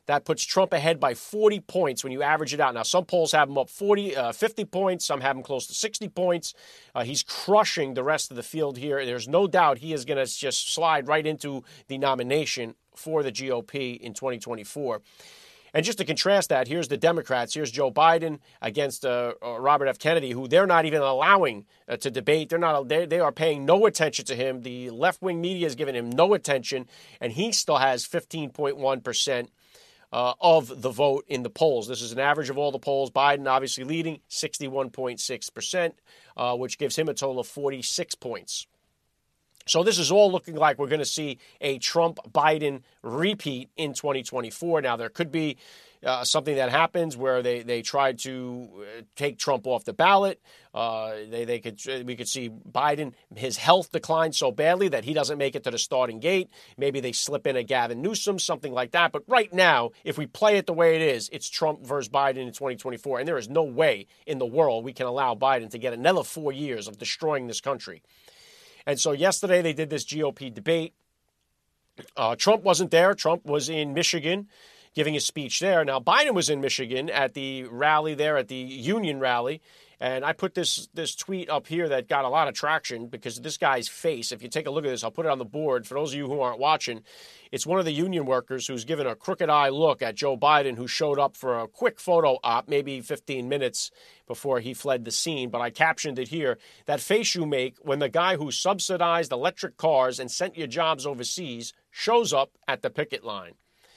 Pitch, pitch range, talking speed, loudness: 145 Hz, 130-170 Hz, 210 wpm, -25 LUFS